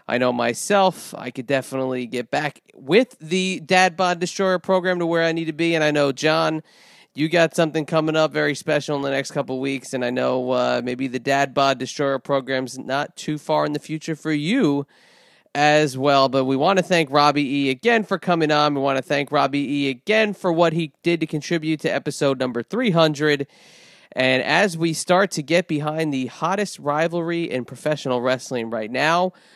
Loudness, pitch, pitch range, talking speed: -21 LUFS, 150 Hz, 135-170 Hz, 205 wpm